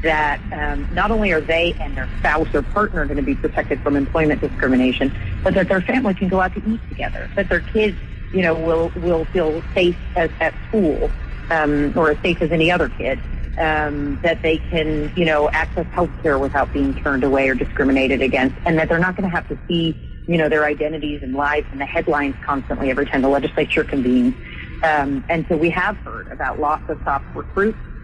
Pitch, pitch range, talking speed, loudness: 155 Hz, 140-170 Hz, 210 wpm, -19 LUFS